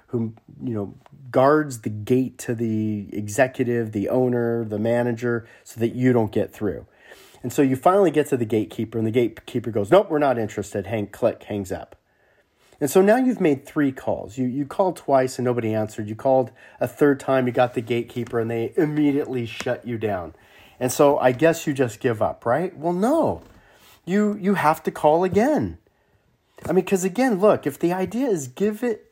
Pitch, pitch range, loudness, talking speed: 125 Hz, 115-155 Hz, -22 LUFS, 200 wpm